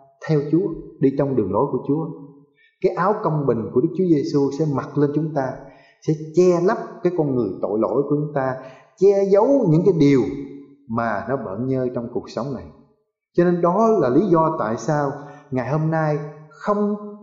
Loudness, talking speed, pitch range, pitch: -20 LUFS, 200 wpm, 135-175 Hz, 150 Hz